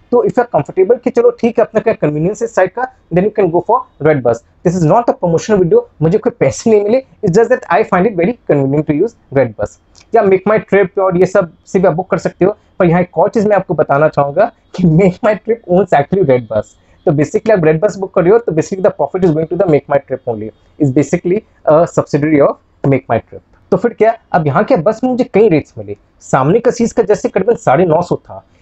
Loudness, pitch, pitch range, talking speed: -13 LUFS, 185 Hz, 150-215 Hz, 120 wpm